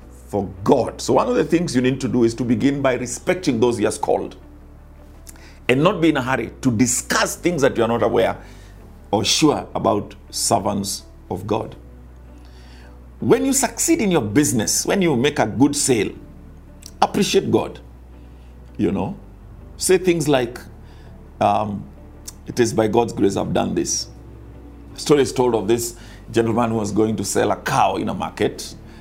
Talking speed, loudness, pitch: 175 wpm, -19 LUFS, 105 Hz